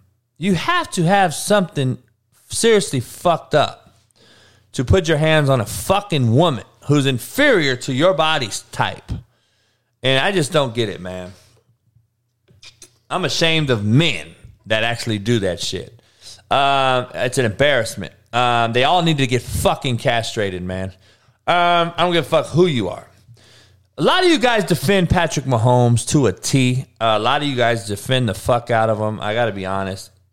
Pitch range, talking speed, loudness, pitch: 110-150 Hz, 170 wpm, -18 LUFS, 120 Hz